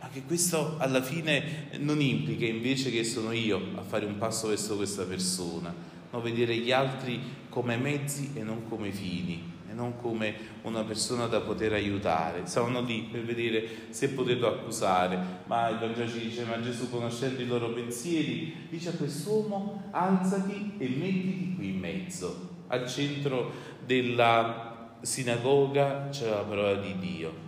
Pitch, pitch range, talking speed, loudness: 120 Hz, 110-140 Hz, 155 wpm, -30 LUFS